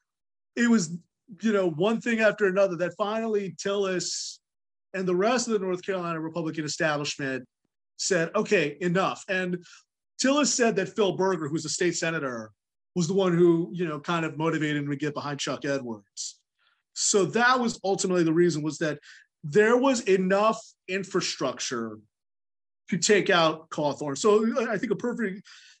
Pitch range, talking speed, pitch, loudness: 155-205 Hz, 160 wpm, 180 Hz, -26 LUFS